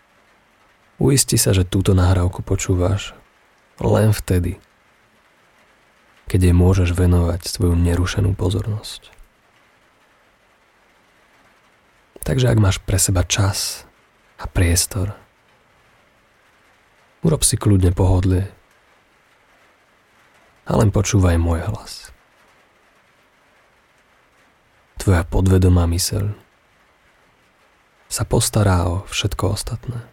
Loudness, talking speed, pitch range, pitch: -18 LUFS, 80 wpm, 90-105 Hz, 95 Hz